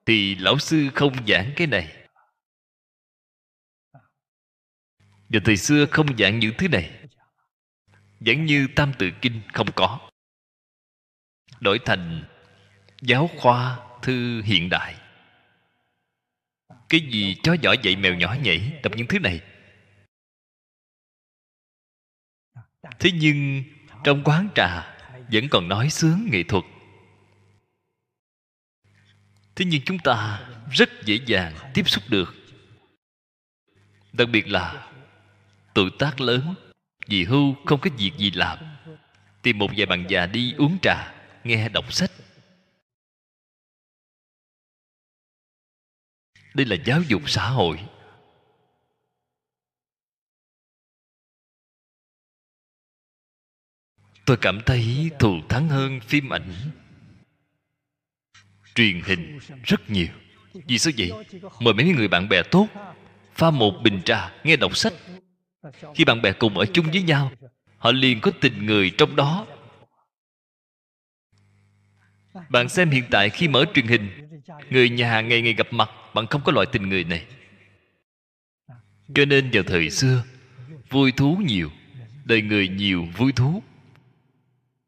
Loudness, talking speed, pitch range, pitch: -21 LUFS, 120 wpm, 100-145 Hz, 120 Hz